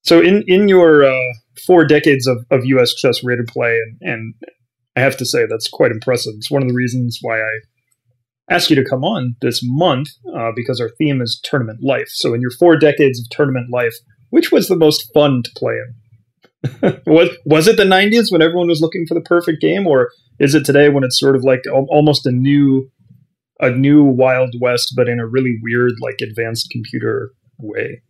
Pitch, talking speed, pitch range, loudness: 130 Hz, 210 wpm, 120-155 Hz, -14 LUFS